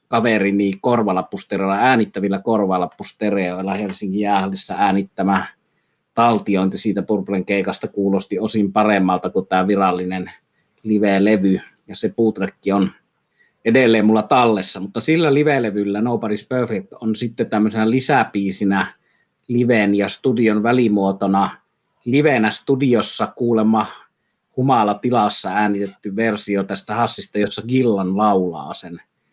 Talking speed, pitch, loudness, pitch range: 110 wpm, 105 Hz, -18 LUFS, 95-115 Hz